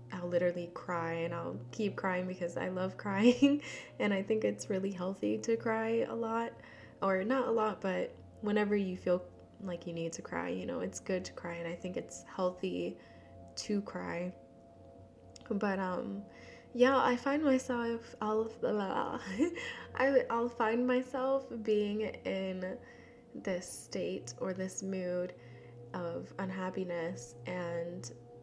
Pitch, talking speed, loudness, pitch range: 190 Hz, 145 wpm, -35 LUFS, 175-225 Hz